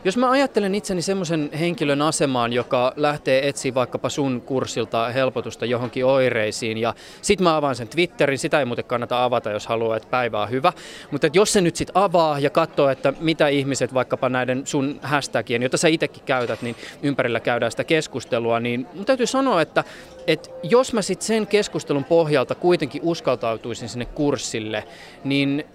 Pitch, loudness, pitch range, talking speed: 140 Hz, -21 LUFS, 125-165 Hz, 175 wpm